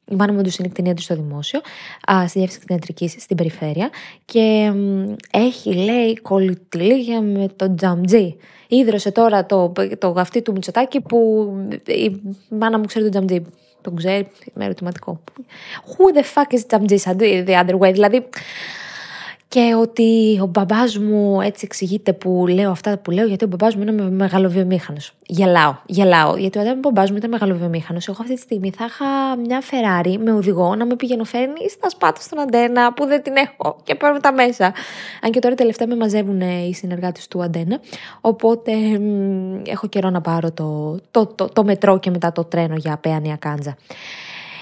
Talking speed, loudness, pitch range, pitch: 175 wpm, -18 LUFS, 185-230 Hz, 200 Hz